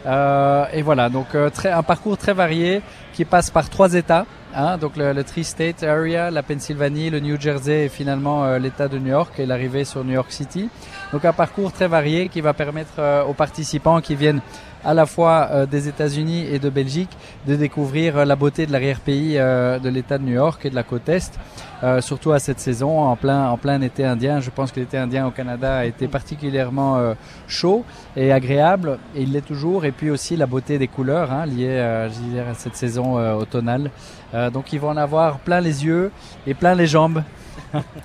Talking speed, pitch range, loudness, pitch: 215 wpm, 130-160 Hz, -20 LUFS, 145 Hz